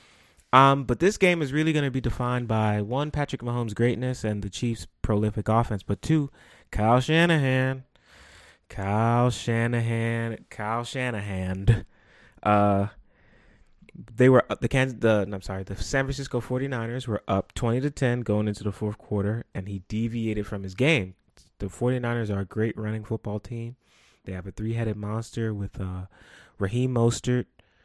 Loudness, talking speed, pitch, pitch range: -26 LUFS, 160 wpm, 115 Hz, 105-125 Hz